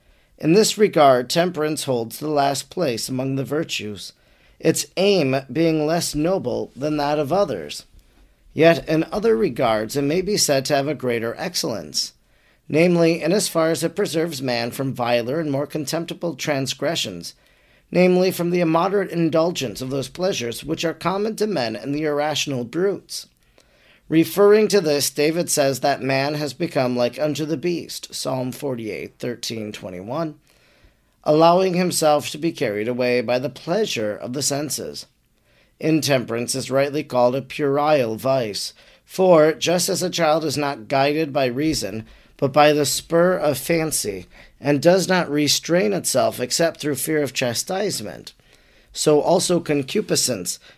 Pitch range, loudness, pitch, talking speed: 135-170 Hz, -20 LUFS, 150 Hz, 150 wpm